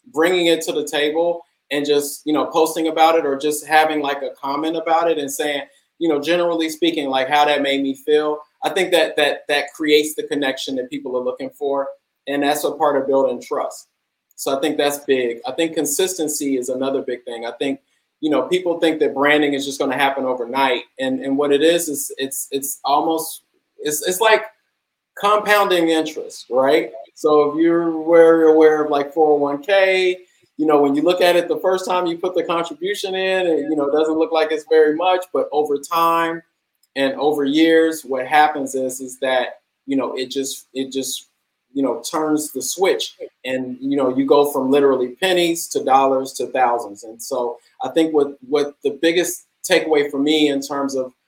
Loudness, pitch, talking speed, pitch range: -18 LUFS, 150 Hz, 200 wpm, 140-165 Hz